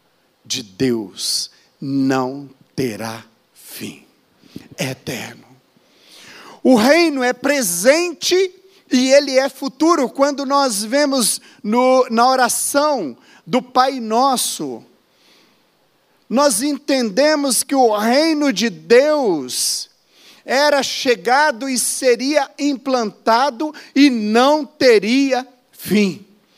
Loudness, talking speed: -16 LUFS, 90 wpm